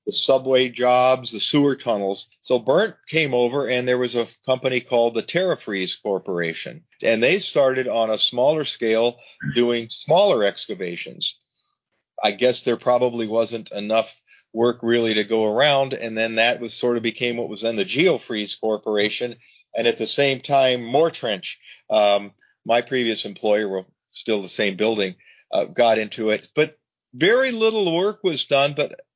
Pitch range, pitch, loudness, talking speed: 110-130 Hz, 120 Hz, -21 LUFS, 165 wpm